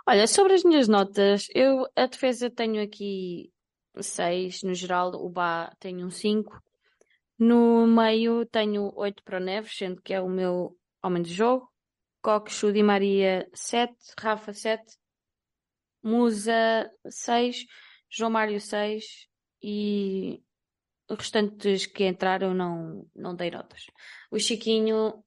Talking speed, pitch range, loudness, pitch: 130 wpm, 190-230 Hz, -25 LUFS, 210 Hz